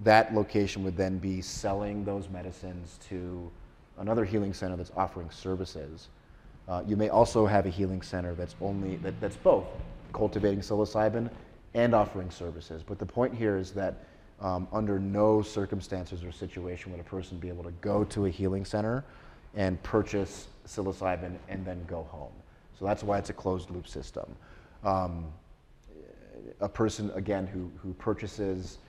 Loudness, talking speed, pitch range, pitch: -31 LUFS, 160 wpm, 90-105 Hz, 95 Hz